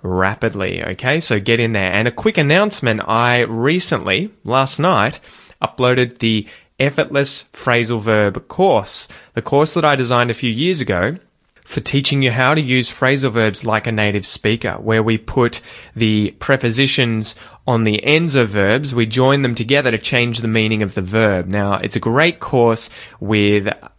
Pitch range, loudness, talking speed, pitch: 110-135 Hz, -16 LUFS, 170 wpm, 120 Hz